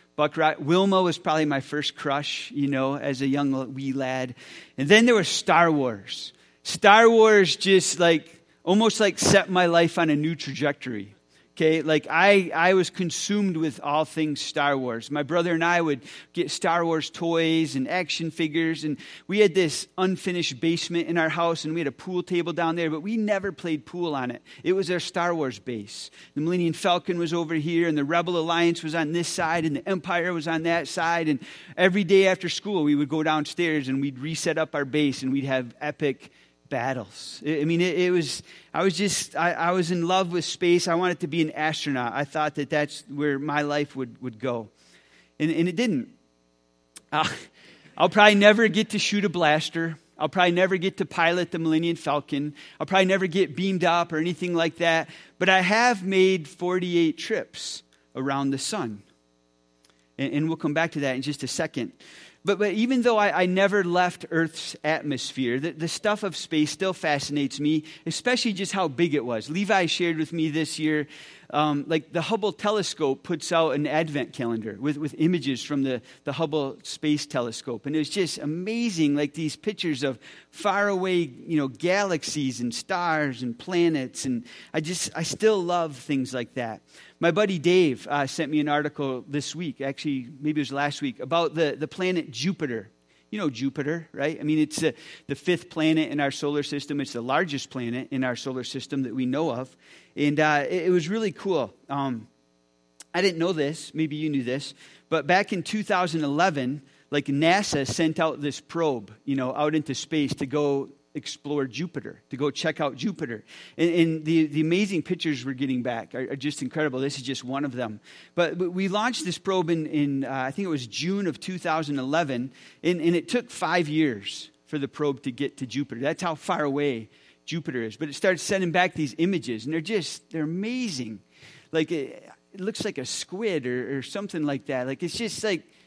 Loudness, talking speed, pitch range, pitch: -25 LUFS, 200 wpm, 140-175 Hz, 155 Hz